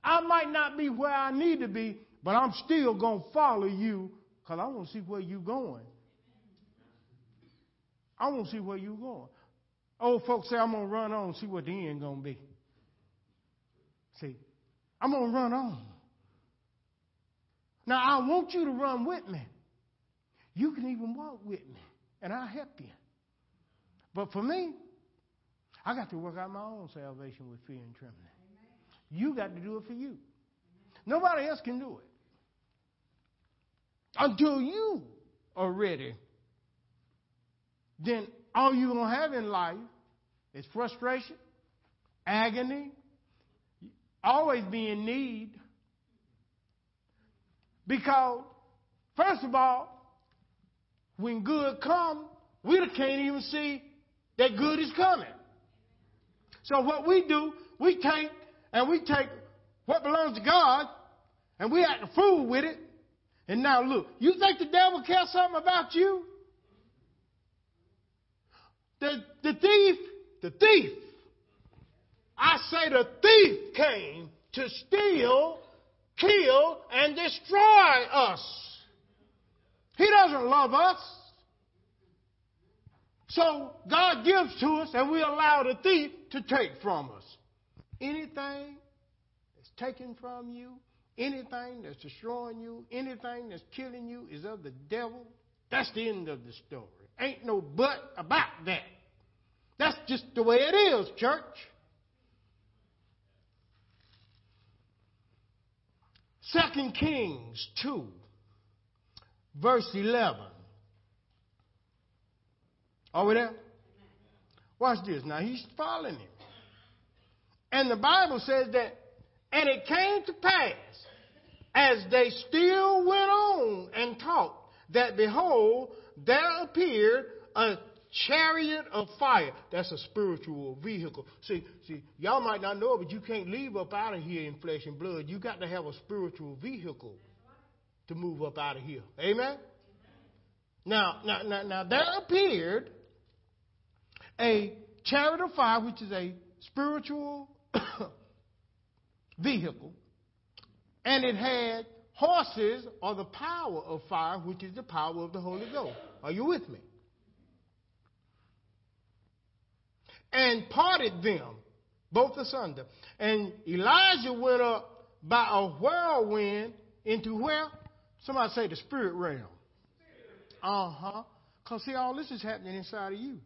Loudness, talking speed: -28 LUFS, 130 wpm